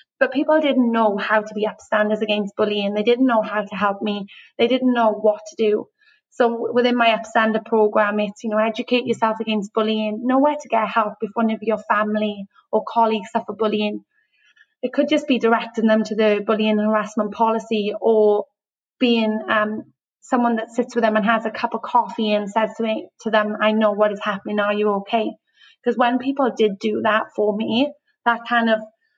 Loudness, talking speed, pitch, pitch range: -20 LUFS, 205 wpm, 220 Hz, 215-235 Hz